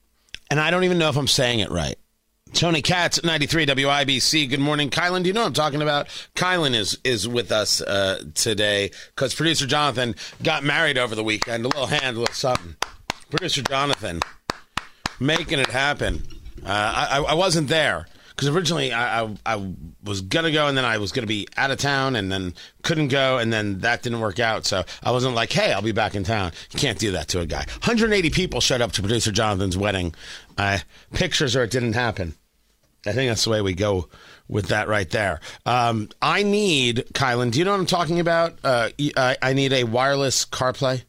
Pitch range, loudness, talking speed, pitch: 105-150 Hz, -21 LUFS, 210 wpm, 125 Hz